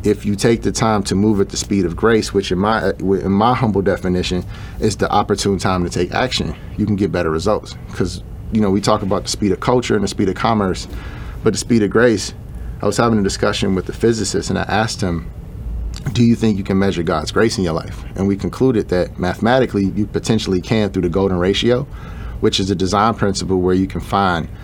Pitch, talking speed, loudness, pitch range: 100 Hz, 230 wpm, -17 LUFS, 95-110 Hz